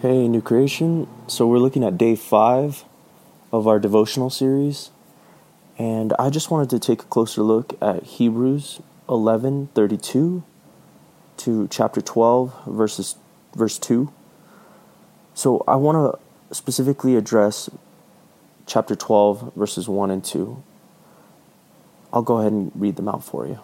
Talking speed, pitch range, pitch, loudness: 135 wpm, 110-135 Hz, 120 Hz, -20 LUFS